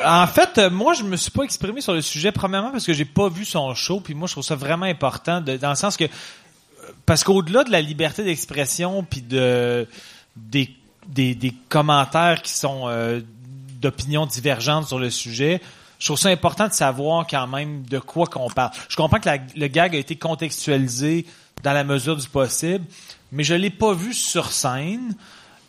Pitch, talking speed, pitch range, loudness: 155 Hz, 200 wpm, 135-180 Hz, -21 LUFS